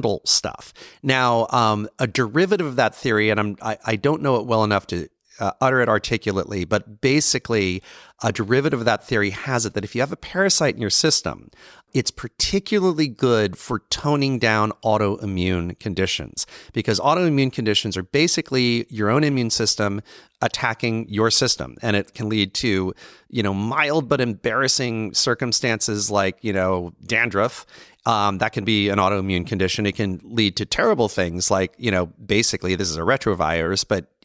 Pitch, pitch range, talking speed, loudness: 110 Hz, 100-125 Hz, 170 wpm, -21 LUFS